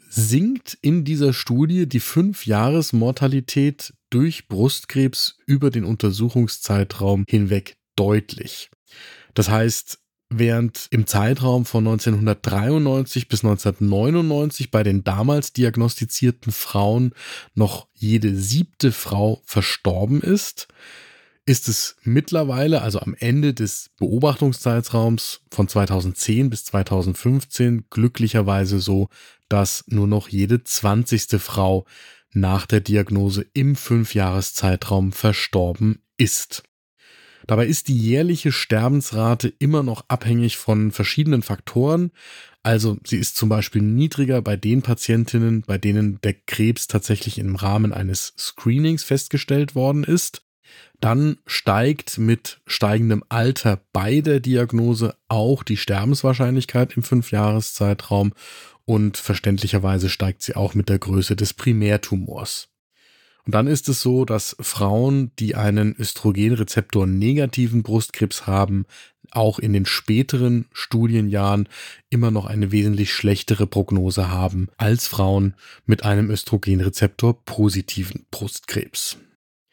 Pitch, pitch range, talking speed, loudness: 110 Hz, 100-130 Hz, 110 wpm, -20 LUFS